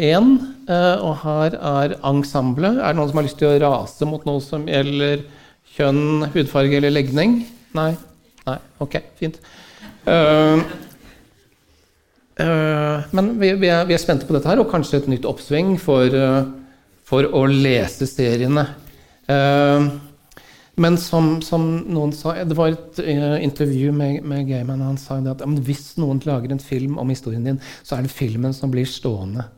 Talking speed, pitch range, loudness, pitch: 165 wpm, 135-160 Hz, -19 LUFS, 145 Hz